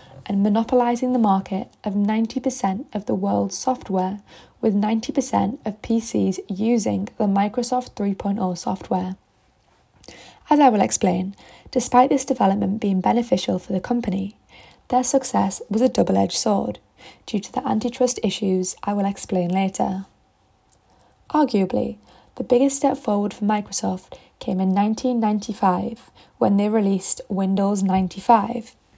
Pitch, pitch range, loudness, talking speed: 210 Hz, 190-245 Hz, -21 LUFS, 130 wpm